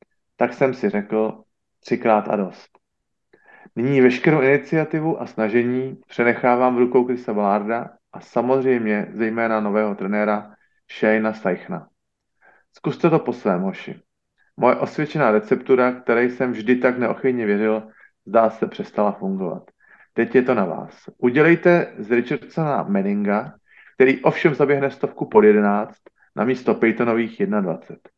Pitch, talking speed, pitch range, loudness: 120 Hz, 130 wpm, 110-135 Hz, -20 LUFS